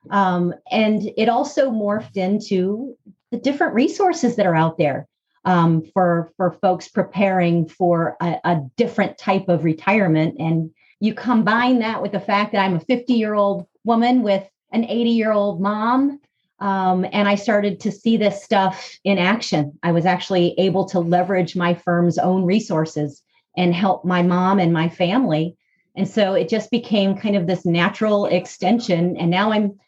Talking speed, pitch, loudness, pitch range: 170 wpm, 195 Hz, -19 LUFS, 175-215 Hz